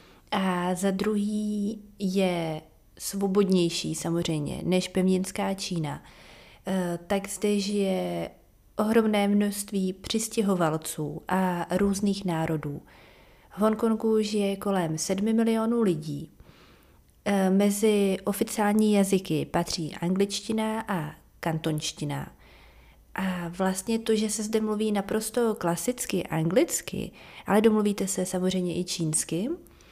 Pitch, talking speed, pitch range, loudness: 195 Hz, 100 wpm, 170-210 Hz, -27 LUFS